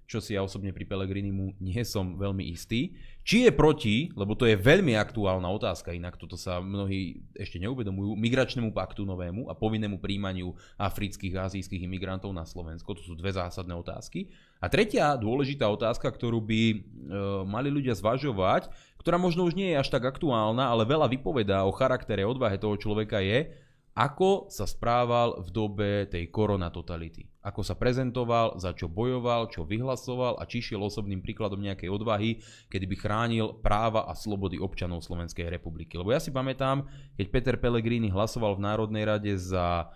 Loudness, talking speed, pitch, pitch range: -29 LUFS, 170 wpm, 105 Hz, 95-120 Hz